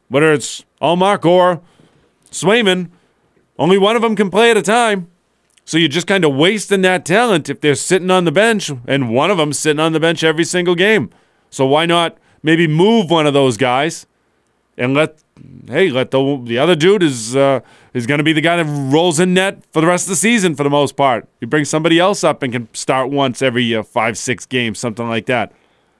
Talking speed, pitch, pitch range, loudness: 220 wpm, 160 Hz, 135-185 Hz, -14 LUFS